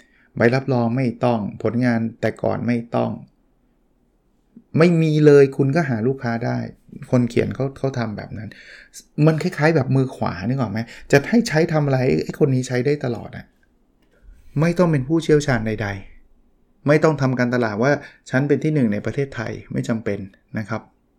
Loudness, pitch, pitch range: -20 LUFS, 130 Hz, 115-145 Hz